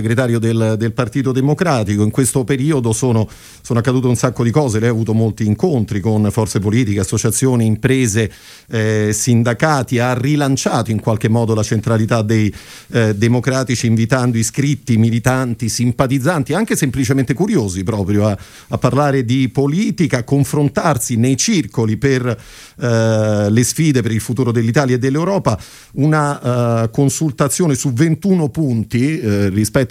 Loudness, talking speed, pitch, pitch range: -16 LUFS, 140 wpm, 125 Hz, 110-140 Hz